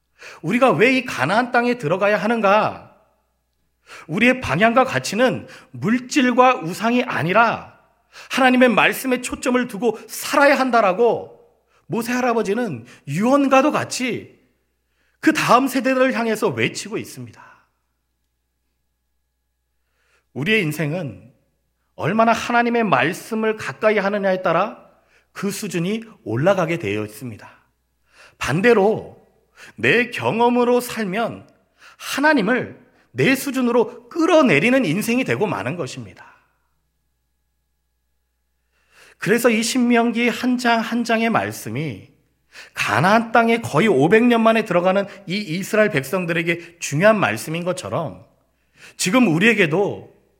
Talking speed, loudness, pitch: 255 characters per minute, -18 LUFS, 215 Hz